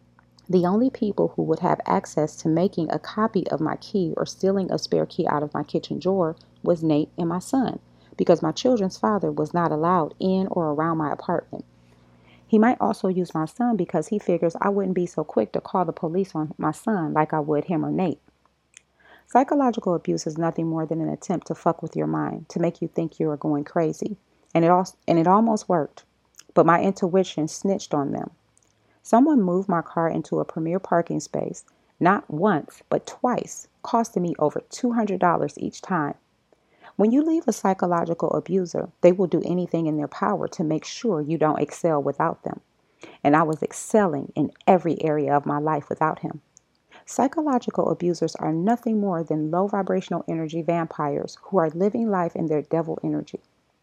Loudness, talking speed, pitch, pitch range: -24 LUFS, 190 wpm, 170 Hz, 155-195 Hz